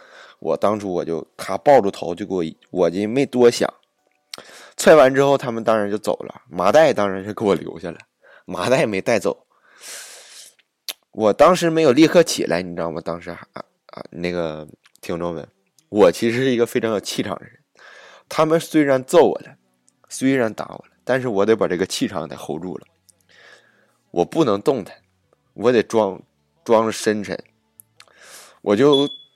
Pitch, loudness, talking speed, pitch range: 110 Hz, -19 LUFS, 245 characters per minute, 85-140 Hz